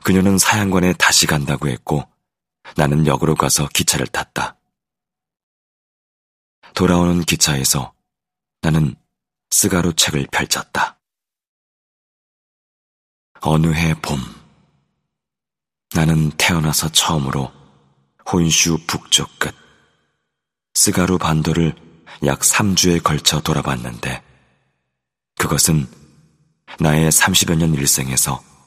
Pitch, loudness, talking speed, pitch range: 80 Hz, -16 LUFS, 190 characters per minute, 70-85 Hz